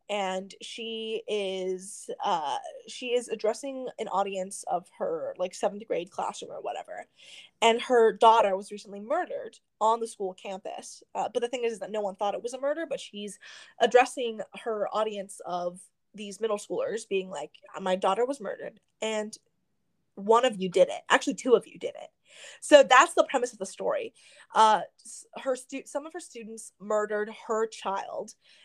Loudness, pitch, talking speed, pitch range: -28 LUFS, 220 Hz, 180 wpm, 195-260 Hz